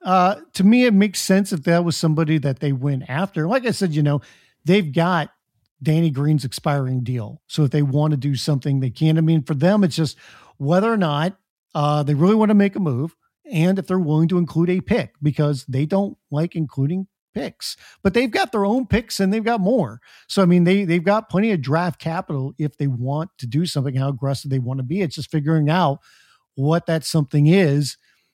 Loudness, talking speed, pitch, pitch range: -20 LUFS, 220 wpm, 160 Hz, 145-190 Hz